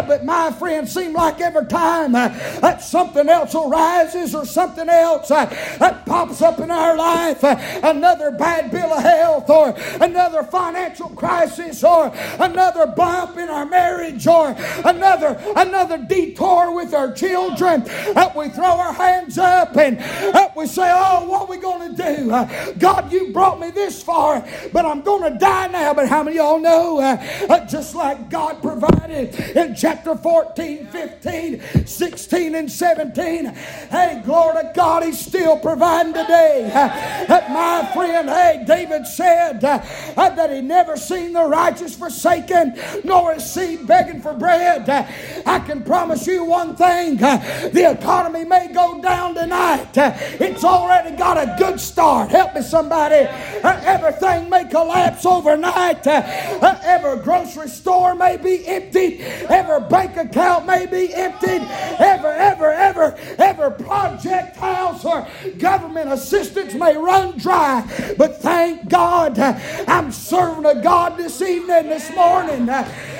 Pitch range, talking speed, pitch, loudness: 305-360 Hz, 150 wpm, 335 Hz, -16 LUFS